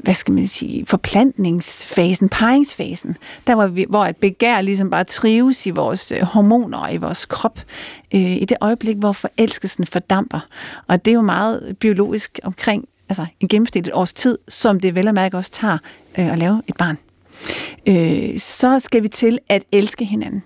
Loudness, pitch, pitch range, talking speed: -17 LUFS, 205 Hz, 185-230 Hz, 175 wpm